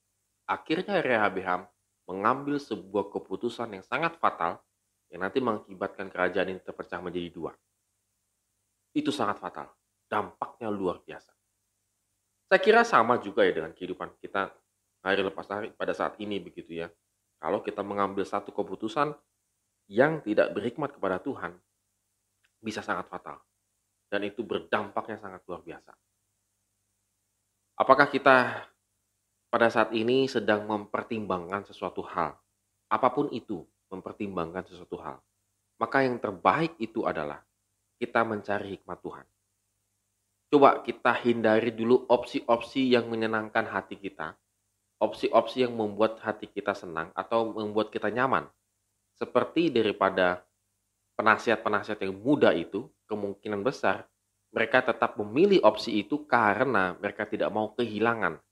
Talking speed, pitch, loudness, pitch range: 120 wpm, 100 Hz, -28 LUFS, 100-115 Hz